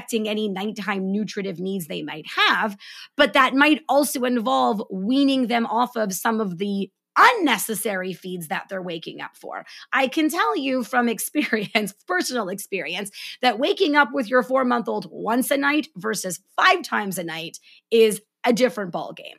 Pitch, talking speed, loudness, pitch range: 225 Hz, 170 wpm, -22 LUFS, 200-260 Hz